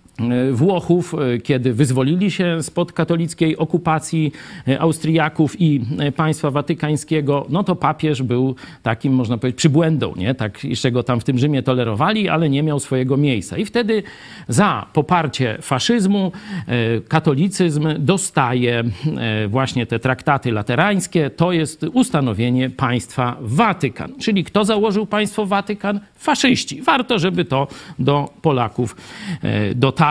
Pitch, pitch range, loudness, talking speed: 150 Hz, 130-175 Hz, -18 LUFS, 125 wpm